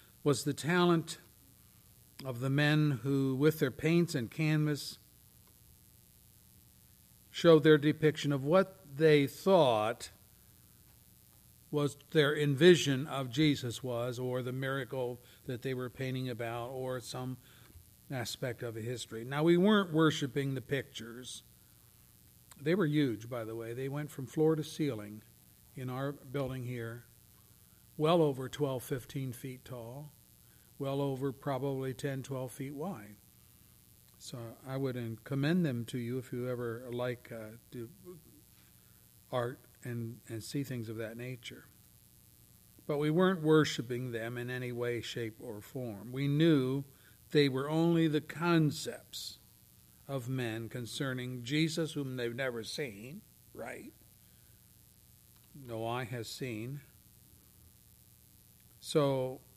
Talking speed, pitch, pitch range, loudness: 130 wpm, 130 Hz, 120-145 Hz, -33 LUFS